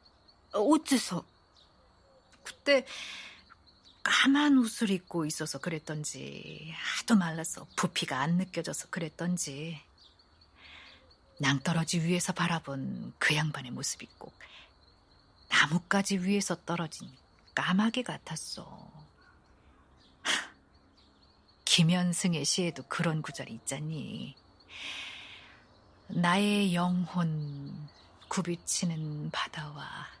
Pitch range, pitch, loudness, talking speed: 135-180 Hz, 165 Hz, -30 LUFS, 190 characters per minute